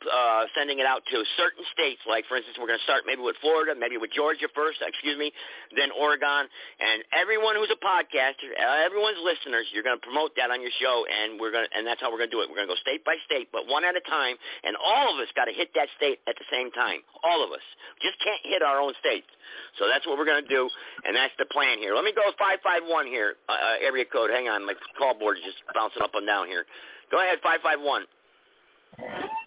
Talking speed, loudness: 250 wpm, -26 LUFS